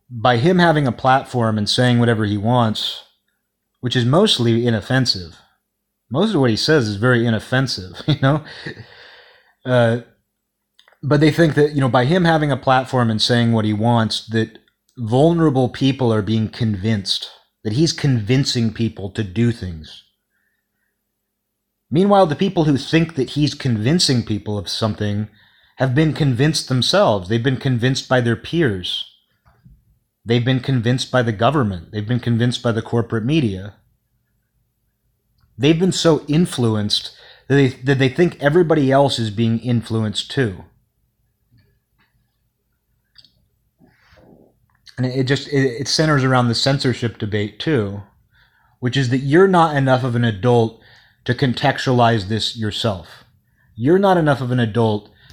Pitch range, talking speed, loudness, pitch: 110-135 Hz, 145 wpm, -18 LUFS, 120 Hz